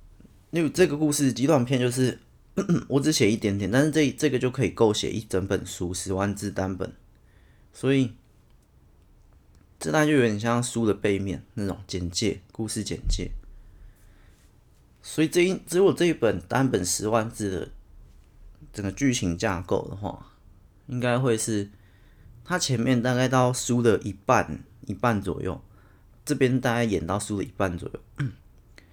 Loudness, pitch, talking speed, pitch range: -25 LUFS, 110 Hz, 225 characters per minute, 95-130 Hz